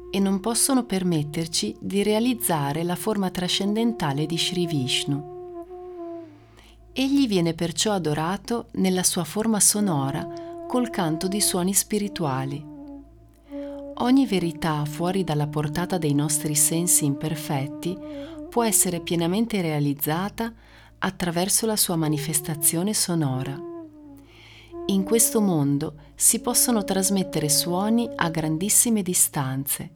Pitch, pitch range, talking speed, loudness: 185 Hz, 160-230 Hz, 105 wpm, -23 LUFS